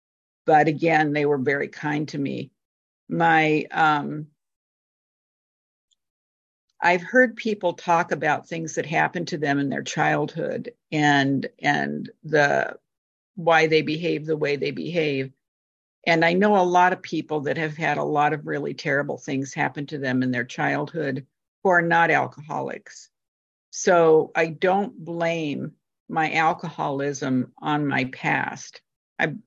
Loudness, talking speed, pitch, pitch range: -23 LUFS, 140 wpm, 155 Hz, 140-165 Hz